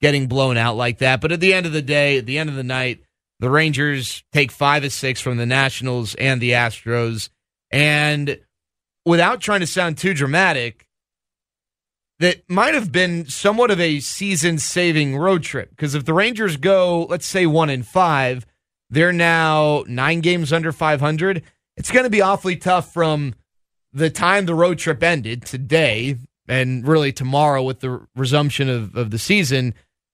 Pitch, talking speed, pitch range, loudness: 145 Hz, 175 wpm, 130-170 Hz, -18 LUFS